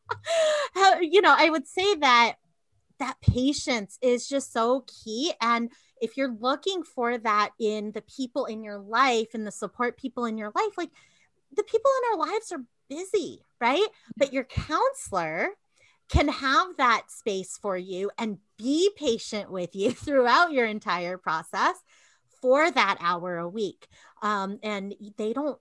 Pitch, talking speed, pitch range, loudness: 245 Hz, 155 wpm, 210-320 Hz, -26 LUFS